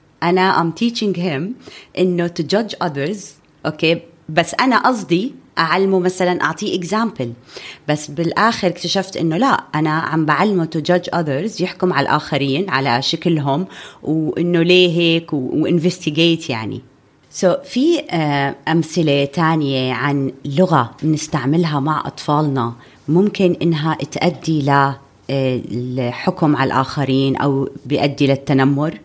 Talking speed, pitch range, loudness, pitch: 120 wpm, 140-180 Hz, -17 LUFS, 160 Hz